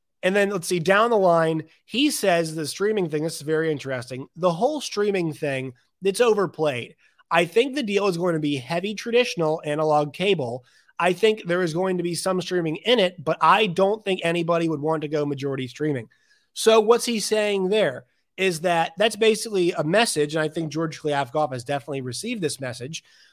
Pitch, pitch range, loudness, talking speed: 170 Hz, 155-205 Hz, -23 LUFS, 200 wpm